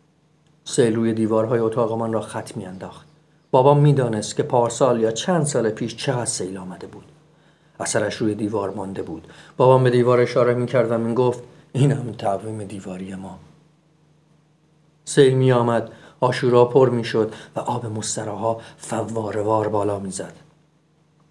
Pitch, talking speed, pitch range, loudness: 120 Hz, 155 wpm, 110-145 Hz, -20 LUFS